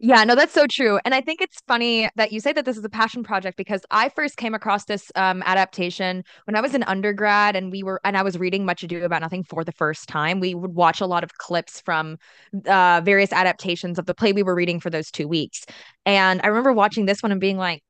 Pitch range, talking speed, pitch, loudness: 180-220 Hz, 260 wpm, 195 Hz, -21 LUFS